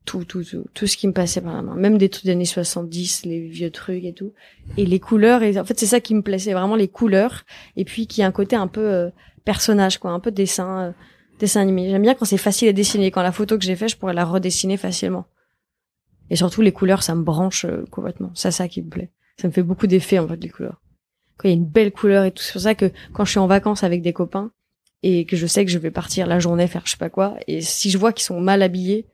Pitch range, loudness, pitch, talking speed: 180-205 Hz, -19 LUFS, 190 Hz, 280 wpm